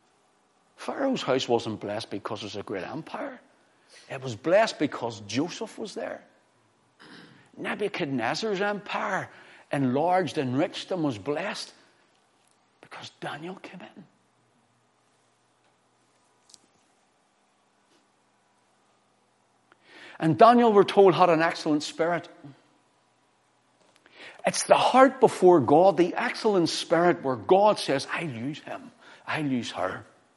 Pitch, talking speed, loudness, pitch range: 170 Hz, 105 wpm, -25 LUFS, 145-205 Hz